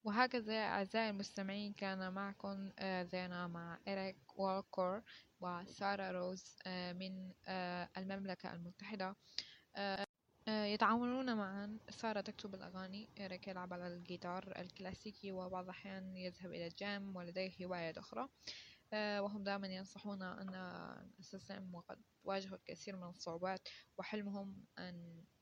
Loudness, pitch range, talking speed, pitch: -45 LUFS, 185-200 Hz, 105 wpm, 190 Hz